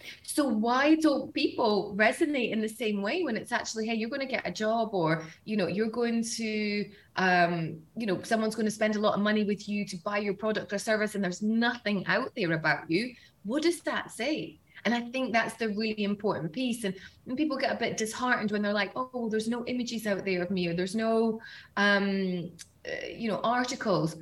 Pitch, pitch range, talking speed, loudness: 215 Hz, 200-235 Hz, 225 wpm, -29 LUFS